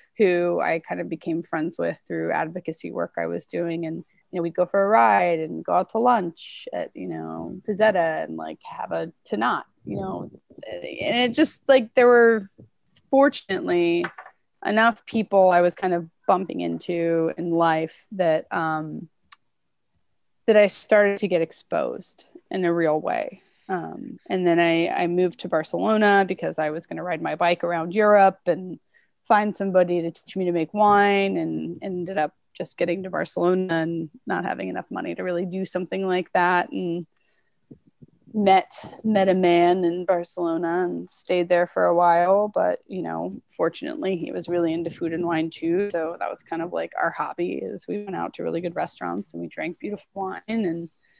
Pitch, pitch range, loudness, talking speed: 175 Hz, 165-195 Hz, -23 LUFS, 185 wpm